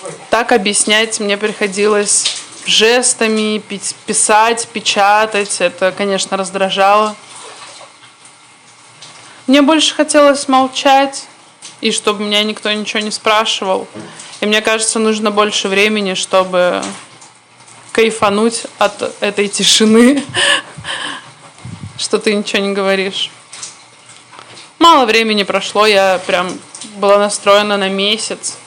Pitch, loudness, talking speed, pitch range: 210 Hz, -12 LUFS, 95 wpm, 200-225 Hz